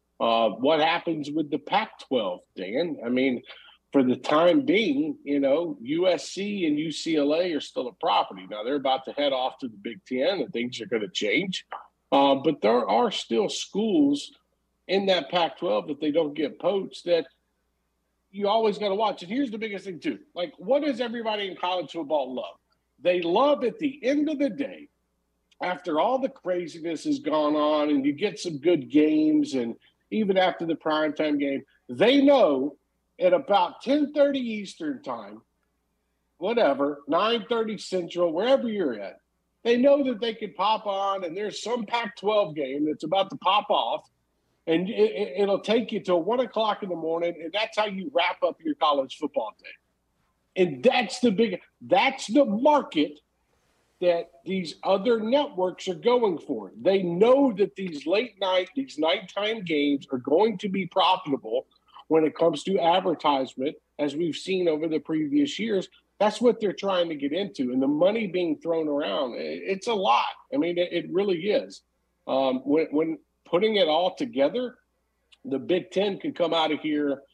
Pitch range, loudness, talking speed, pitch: 155-235 Hz, -25 LUFS, 180 wpm, 185 Hz